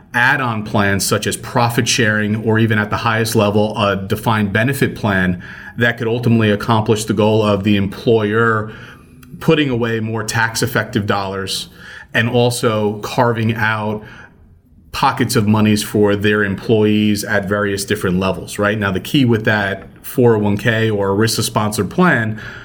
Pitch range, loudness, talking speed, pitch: 105-115 Hz, -16 LUFS, 150 wpm, 110 Hz